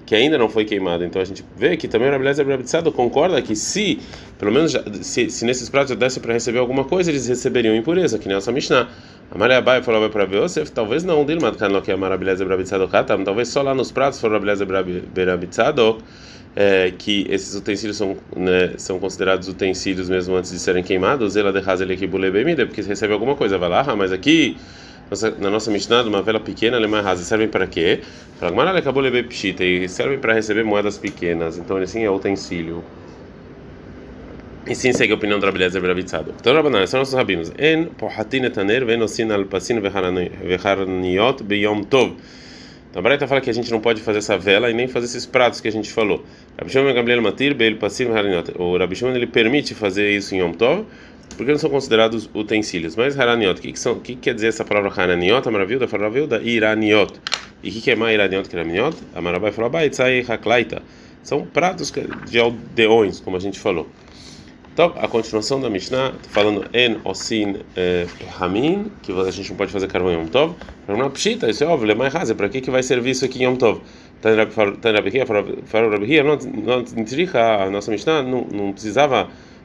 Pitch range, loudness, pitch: 95-125 Hz, -19 LUFS, 105 Hz